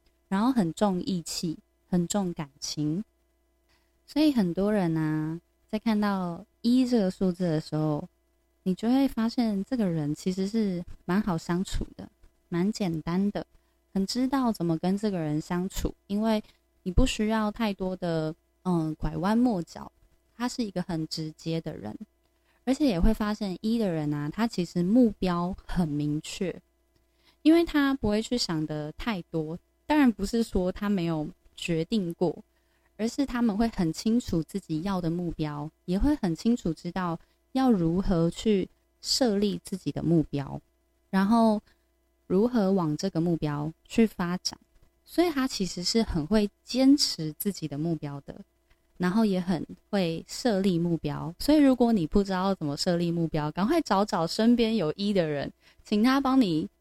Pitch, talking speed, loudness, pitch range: 195 Hz, 230 characters per minute, -28 LUFS, 165-230 Hz